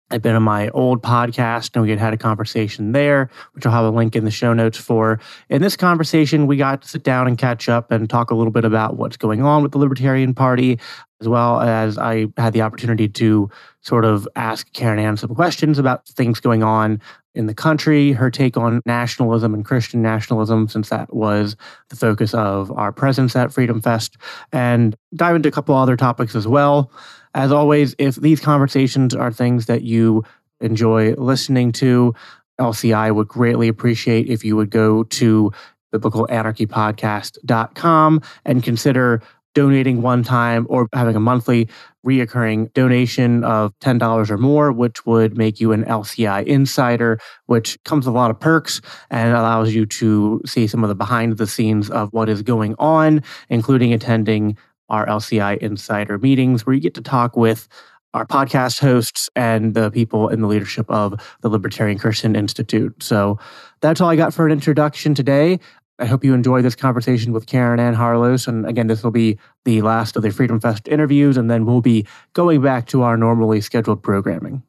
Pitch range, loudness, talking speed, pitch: 110-130 Hz, -17 LUFS, 185 wpm, 120 Hz